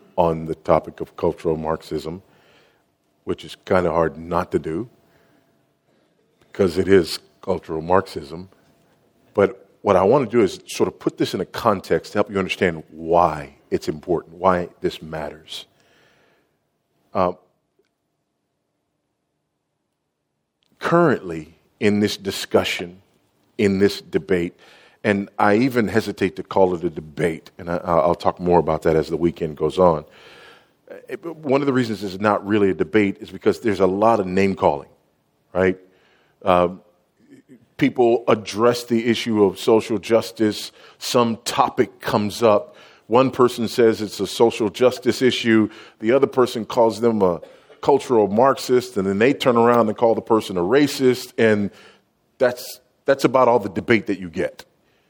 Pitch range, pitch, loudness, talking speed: 90-115 Hz, 100 Hz, -20 LUFS, 150 wpm